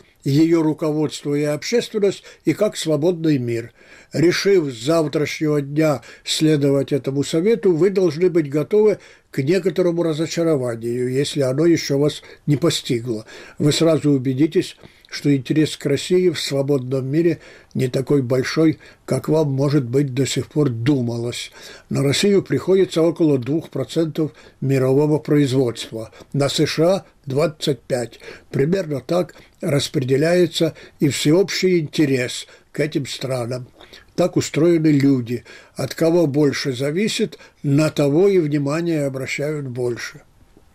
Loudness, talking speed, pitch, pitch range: -19 LUFS, 120 wpm, 150 Hz, 140-165 Hz